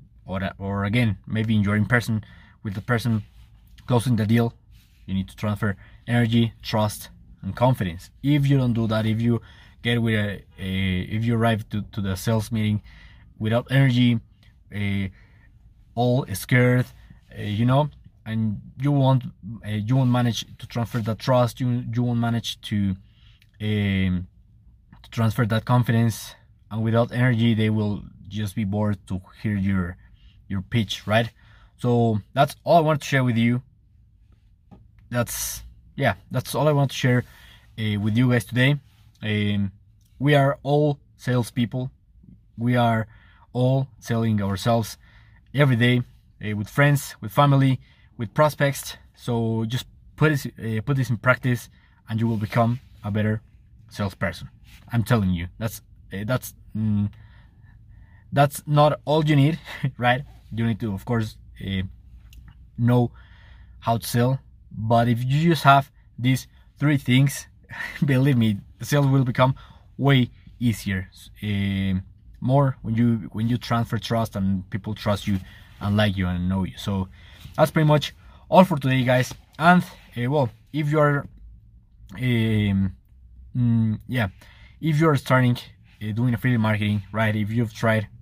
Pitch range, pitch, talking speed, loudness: 105-125 Hz, 110 Hz, 155 wpm, -23 LUFS